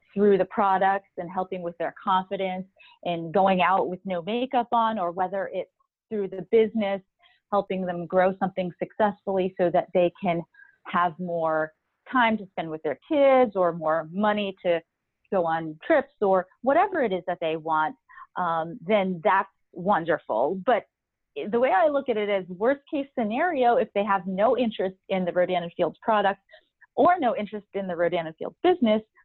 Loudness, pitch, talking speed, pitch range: -25 LUFS, 195 Hz, 180 wpm, 180-235 Hz